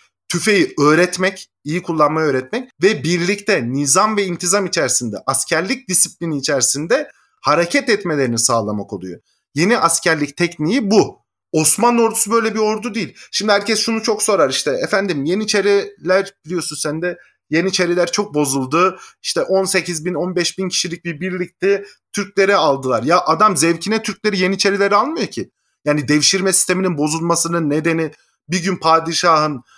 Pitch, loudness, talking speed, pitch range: 180 Hz, -16 LUFS, 135 wpm, 155-205 Hz